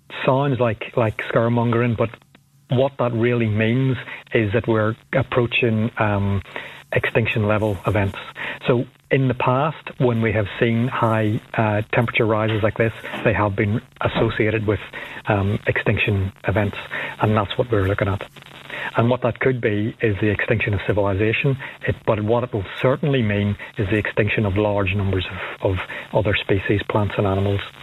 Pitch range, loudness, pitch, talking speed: 105-125 Hz, -21 LUFS, 115 Hz, 160 wpm